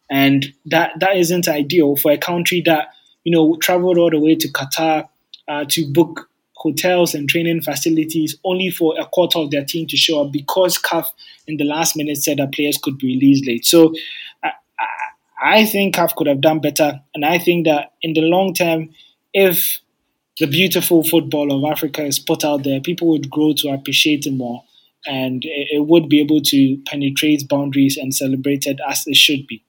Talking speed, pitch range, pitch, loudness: 195 wpm, 145-170 Hz, 155 Hz, -16 LUFS